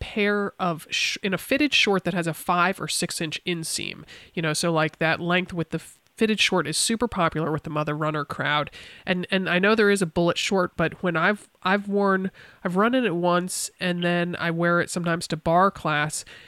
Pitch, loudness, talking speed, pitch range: 175 Hz, -24 LUFS, 220 wpm, 165-195 Hz